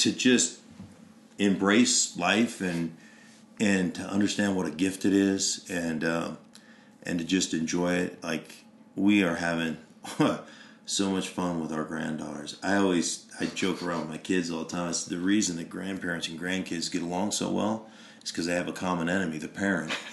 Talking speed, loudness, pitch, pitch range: 180 wpm, -28 LUFS, 90 Hz, 85-100 Hz